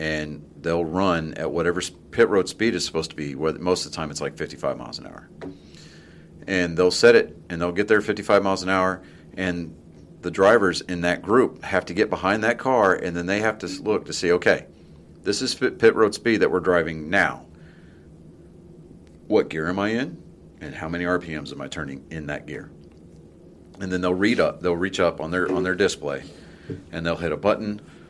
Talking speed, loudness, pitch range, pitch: 210 wpm, -23 LUFS, 80-95 Hz, 90 Hz